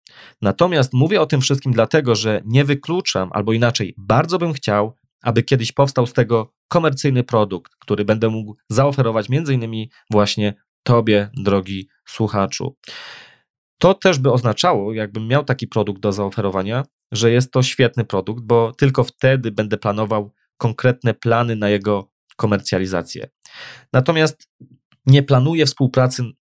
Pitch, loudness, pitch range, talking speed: 115 Hz, -18 LUFS, 105-135 Hz, 135 wpm